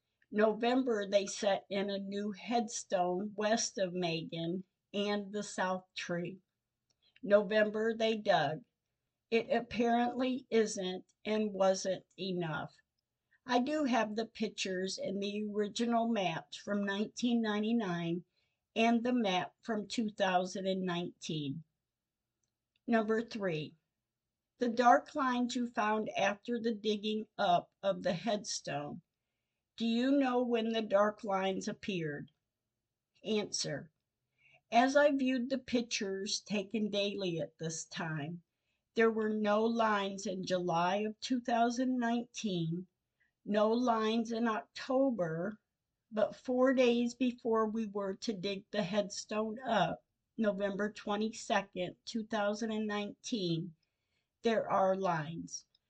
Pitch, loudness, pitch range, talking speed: 205 Hz, -34 LUFS, 185-230 Hz, 115 wpm